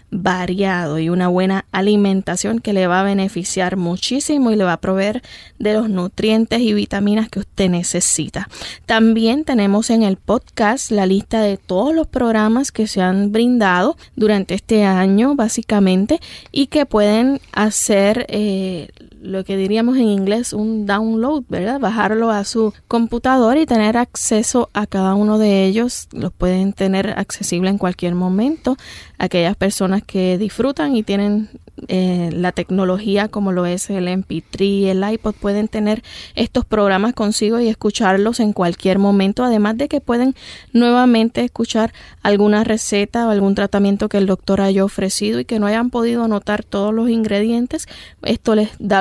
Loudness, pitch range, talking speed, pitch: -17 LUFS, 195-225 Hz, 160 wpm, 210 Hz